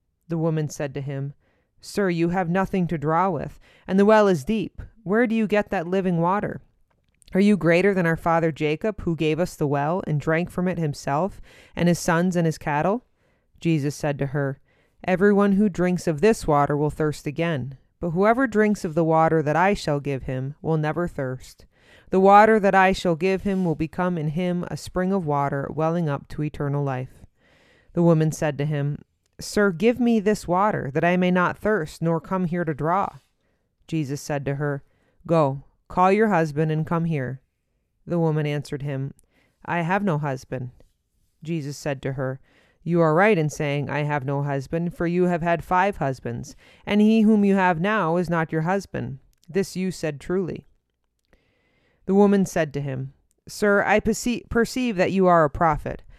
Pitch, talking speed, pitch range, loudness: 165 Hz, 190 wpm, 145-190 Hz, -23 LUFS